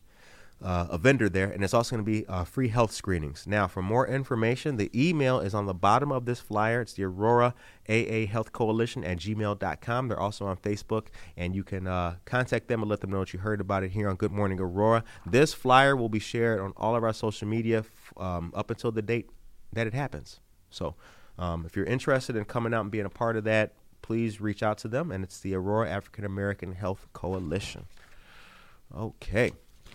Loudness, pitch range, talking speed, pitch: -29 LUFS, 95-115 Hz, 215 wpm, 110 Hz